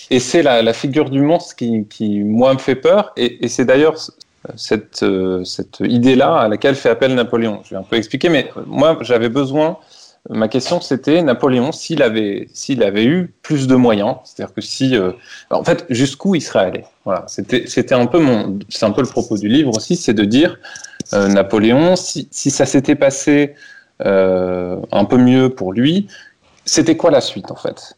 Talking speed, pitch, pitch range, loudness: 195 wpm, 130 Hz, 110-150 Hz, -15 LUFS